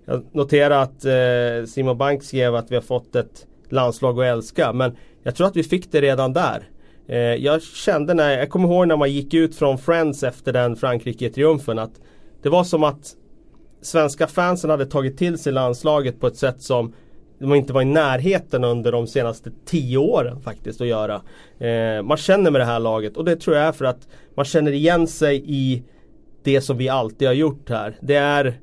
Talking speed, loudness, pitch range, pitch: 205 wpm, -20 LUFS, 120-155 Hz, 135 Hz